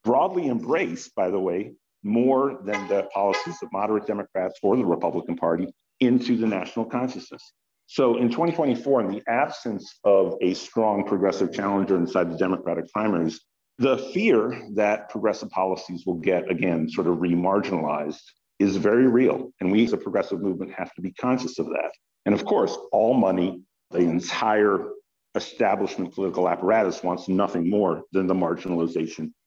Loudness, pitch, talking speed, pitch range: -24 LUFS, 100 Hz, 160 wpm, 90-120 Hz